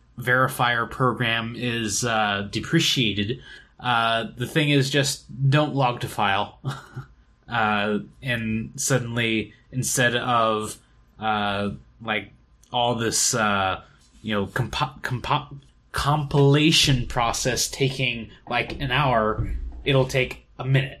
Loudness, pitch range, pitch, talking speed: -23 LUFS, 110-135 Hz, 120 Hz, 110 wpm